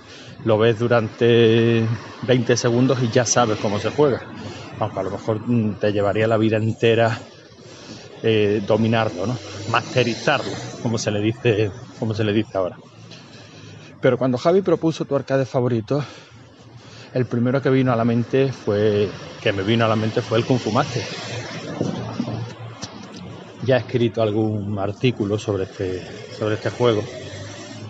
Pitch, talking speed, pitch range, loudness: 115 Hz, 145 wpm, 110-125 Hz, -21 LUFS